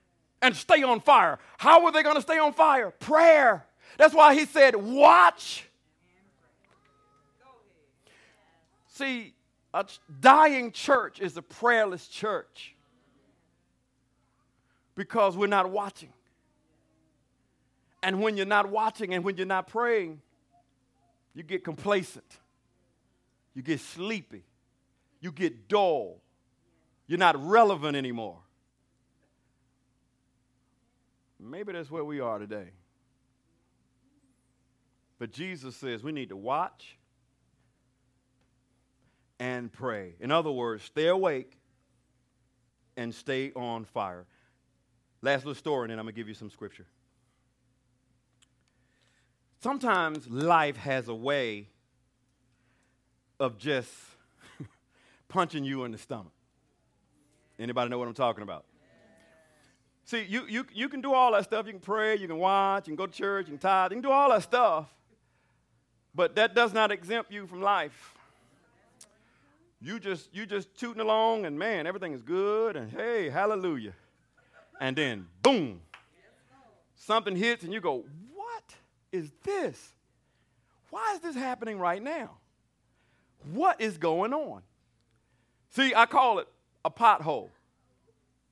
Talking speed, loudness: 125 wpm, -26 LUFS